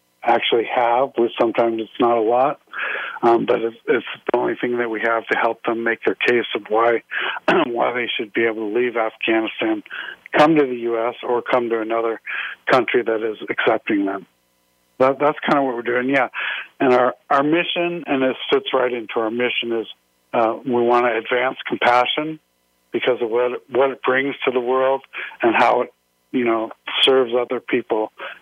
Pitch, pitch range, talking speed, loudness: 120 Hz, 115-130 Hz, 190 wpm, -19 LUFS